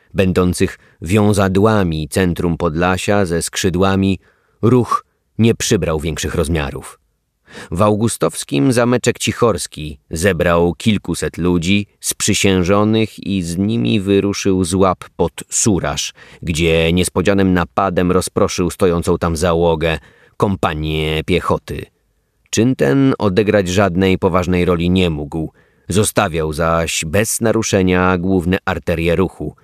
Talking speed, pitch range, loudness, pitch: 105 wpm, 85-100 Hz, -16 LUFS, 95 Hz